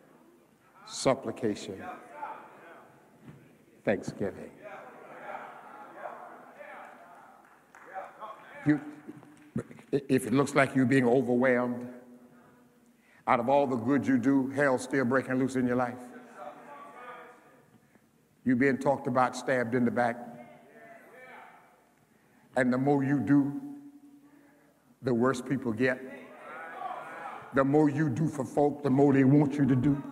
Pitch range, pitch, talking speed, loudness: 125-145 Hz, 135 Hz, 110 wpm, -28 LUFS